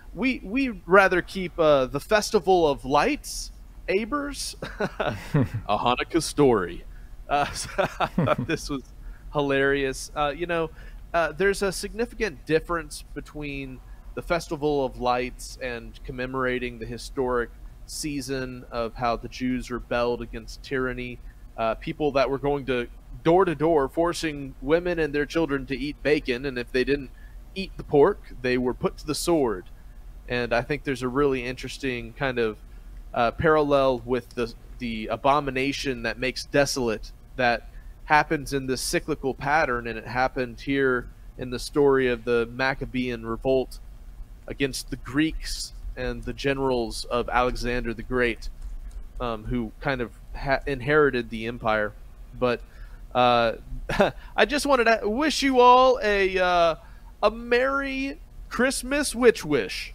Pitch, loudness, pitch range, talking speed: 135 Hz, -25 LUFS, 120-155 Hz, 145 wpm